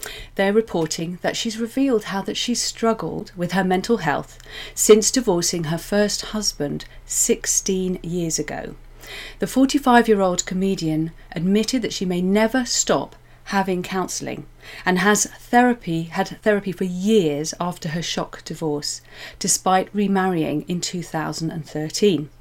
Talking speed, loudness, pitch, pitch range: 125 wpm, -21 LUFS, 185 Hz, 165-215 Hz